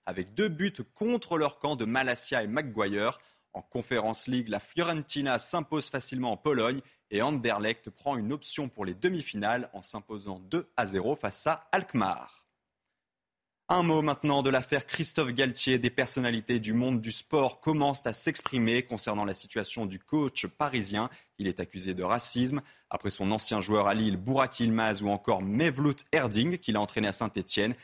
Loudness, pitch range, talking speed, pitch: -29 LUFS, 105-145 Hz, 170 wpm, 120 Hz